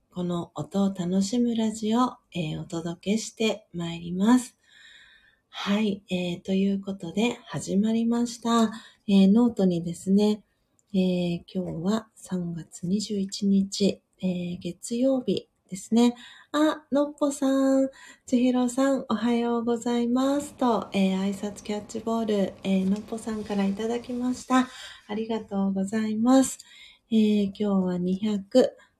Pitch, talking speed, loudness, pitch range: 210 Hz, 260 characters per minute, -26 LUFS, 190-235 Hz